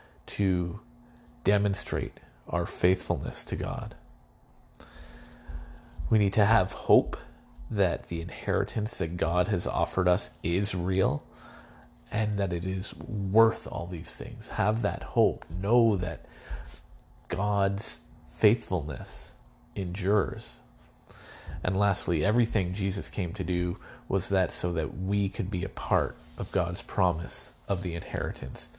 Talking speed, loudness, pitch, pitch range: 125 wpm, -28 LUFS, 95 Hz, 90-105 Hz